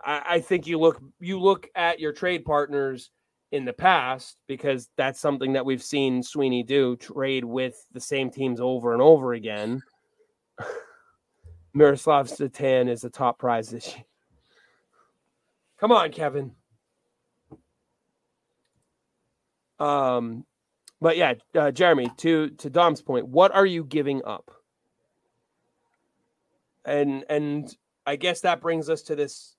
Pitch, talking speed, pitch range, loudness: 140 Hz, 130 wpm, 125-165 Hz, -24 LUFS